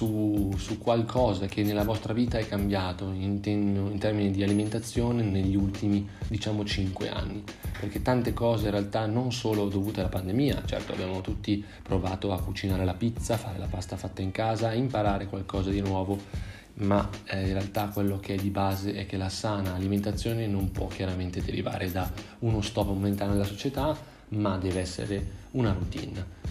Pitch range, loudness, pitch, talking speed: 95-110 Hz, -29 LUFS, 100 Hz, 175 wpm